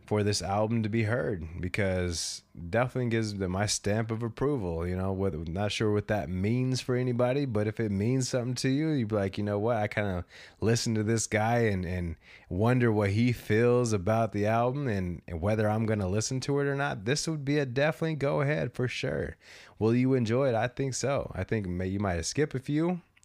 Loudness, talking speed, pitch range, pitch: -29 LUFS, 225 wpm, 100-125 Hz, 110 Hz